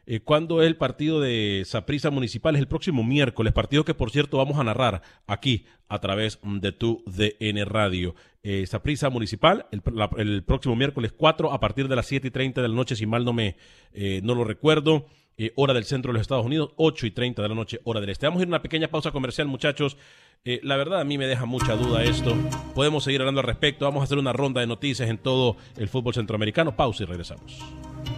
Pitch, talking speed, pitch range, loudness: 125 Hz, 230 wpm, 110-140 Hz, -25 LUFS